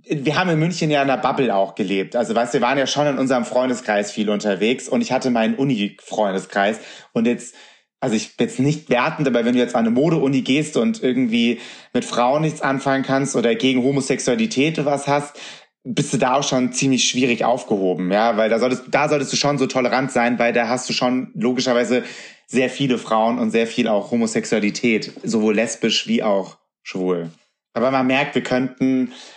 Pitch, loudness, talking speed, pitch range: 125 Hz, -19 LUFS, 200 wpm, 115-135 Hz